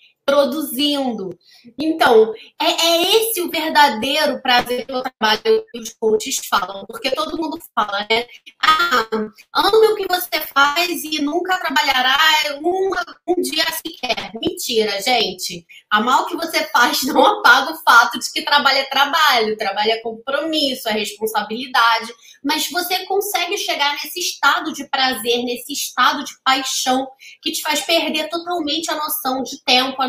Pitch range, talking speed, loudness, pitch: 240-330 Hz, 150 wpm, -17 LUFS, 285 Hz